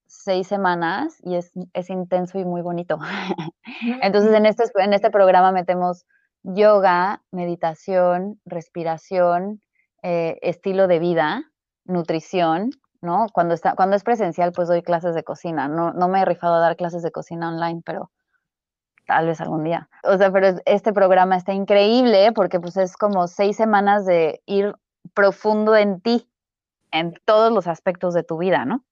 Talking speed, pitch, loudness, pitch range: 160 wpm, 185 Hz, -20 LUFS, 170-200 Hz